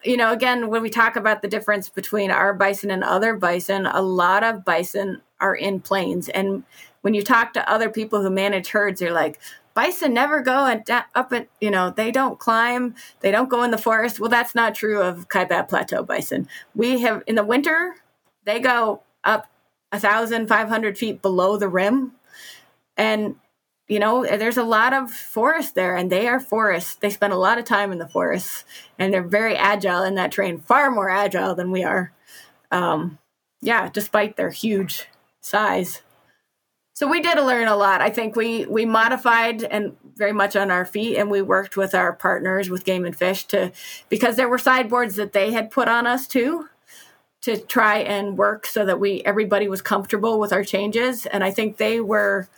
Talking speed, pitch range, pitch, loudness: 195 wpm, 195-230 Hz, 210 Hz, -20 LUFS